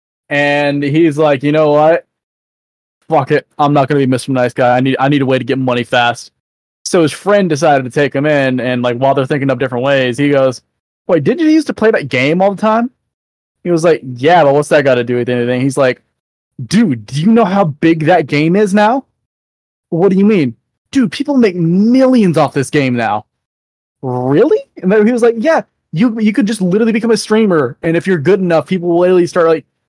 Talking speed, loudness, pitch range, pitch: 230 wpm, -12 LUFS, 130-200 Hz, 150 Hz